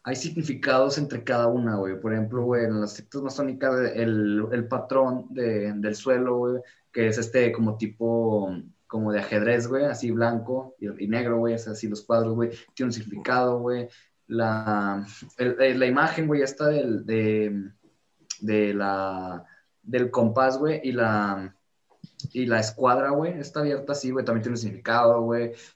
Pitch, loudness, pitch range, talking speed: 120 Hz, -25 LUFS, 110-130 Hz, 170 wpm